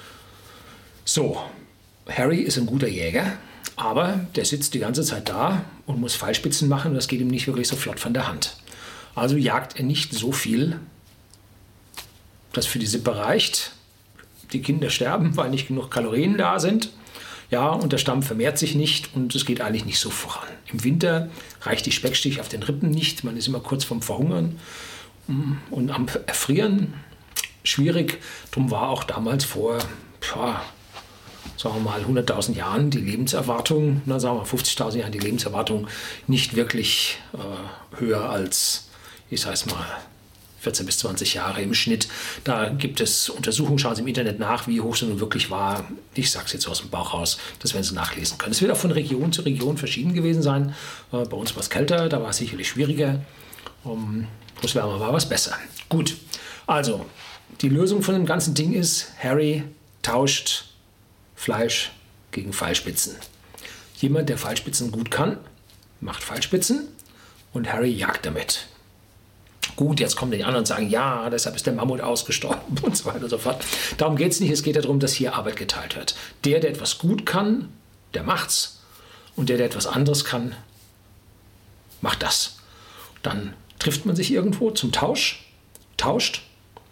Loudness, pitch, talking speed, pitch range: -23 LUFS, 125 Hz, 175 wpm, 110-150 Hz